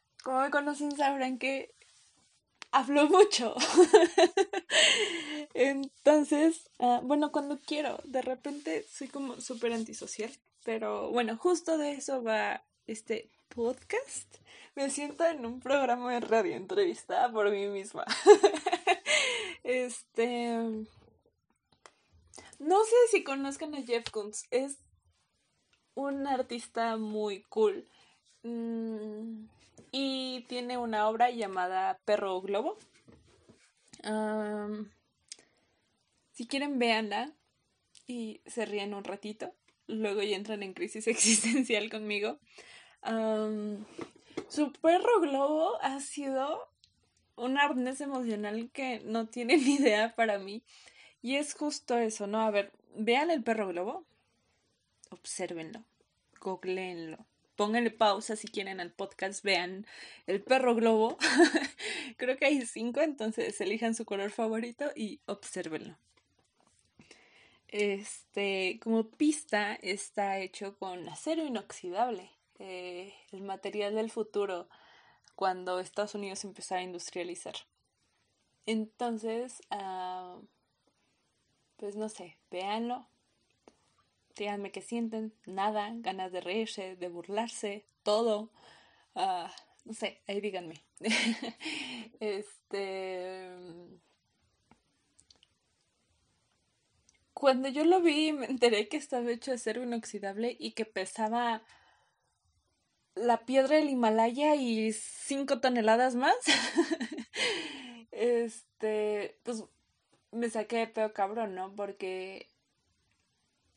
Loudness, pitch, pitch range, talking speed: -31 LUFS, 230 Hz, 205-275 Hz, 105 wpm